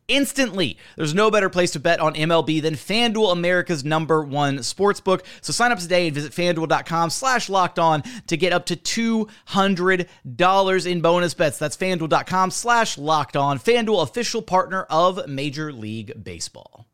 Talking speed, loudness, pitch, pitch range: 165 wpm, -20 LUFS, 175 Hz, 155-195 Hz